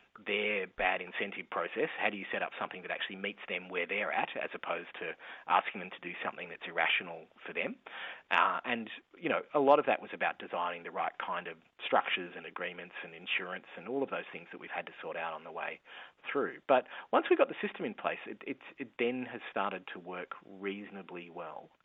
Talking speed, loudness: 225 wpm, -35 LUFS